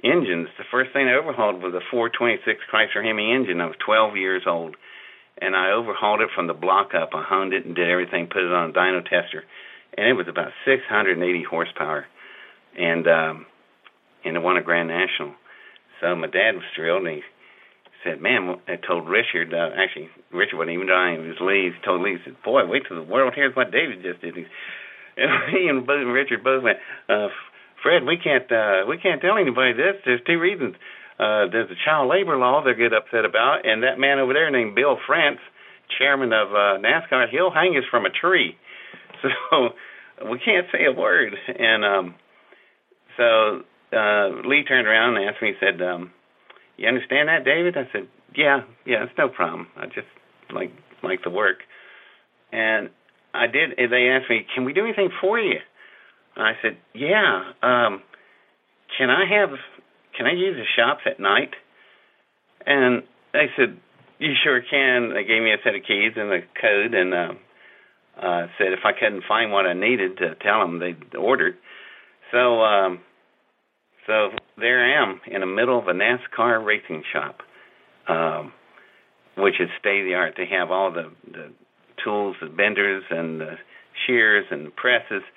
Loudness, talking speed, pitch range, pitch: -21 LUFS, 190 wpm, 90-125 Hz, 105 Hz